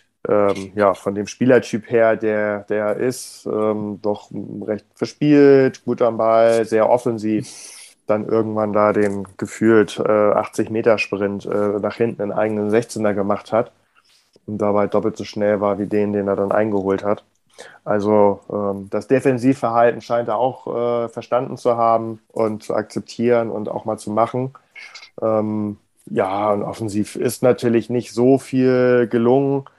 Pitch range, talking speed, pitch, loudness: 105-120 Hz, 150 wpm, 110 Hz, -19 LUFS